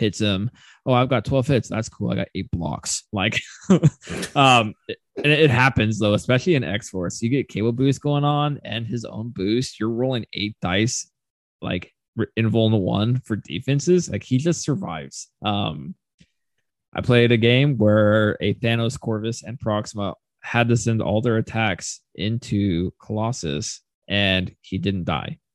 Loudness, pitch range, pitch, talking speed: -22 LUFS, 100-125 Hz, 110 Hz, 165 wpm